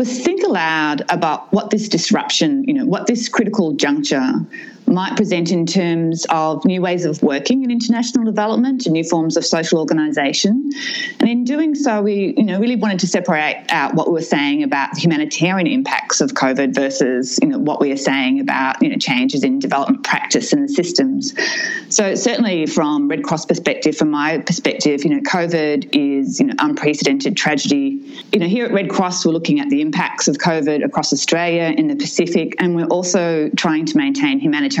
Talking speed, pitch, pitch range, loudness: 190 wpm, 210 Hz, 165-275 Hz, -17 LUFS